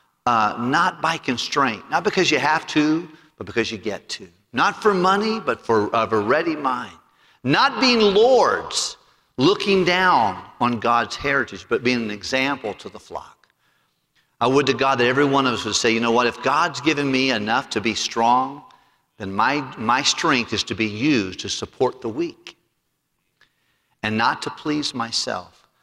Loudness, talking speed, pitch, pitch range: -20 LUFS, 180 wpm, 140 Hz, 120-170 Hz